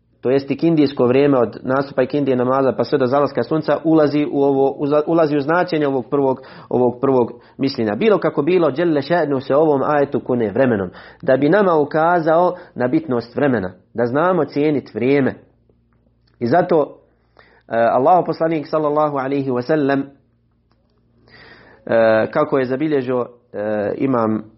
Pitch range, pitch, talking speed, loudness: 125-150 Hz, 140 Hz, 150 wpm, -17 LUFS